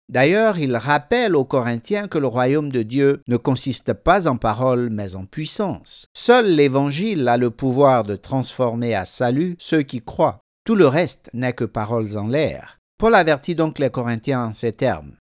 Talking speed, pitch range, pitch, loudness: 180 wpm, 120-150 Hz, 130 Hz, -19 LUFS